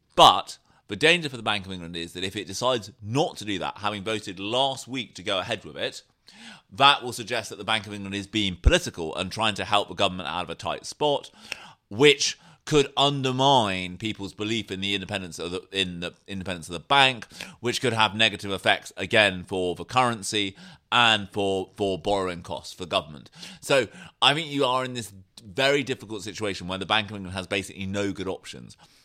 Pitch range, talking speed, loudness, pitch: 95-125 Hz, 210 wpm, -25 LUFS, 105 Hz